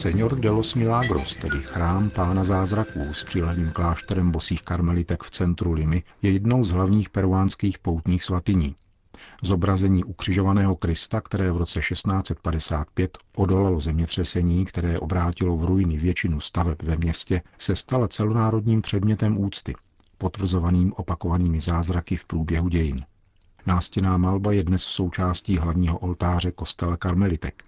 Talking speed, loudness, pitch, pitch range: 130 wpm, -24 LUFS, 90 Hz, 85-95 Hz